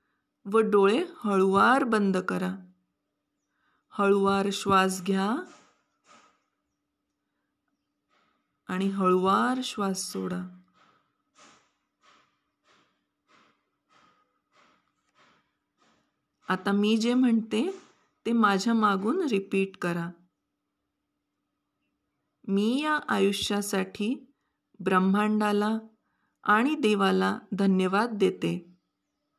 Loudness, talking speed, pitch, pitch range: -26 LUFS, 60 wpm, 200 Hz, 185-220 Hz